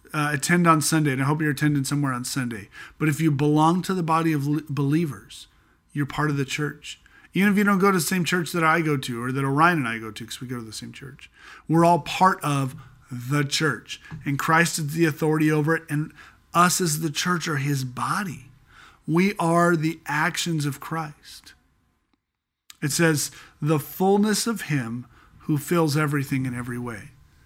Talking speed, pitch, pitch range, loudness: 205 wpm, 150 Hz, 140-165 Hz, -23 LUFS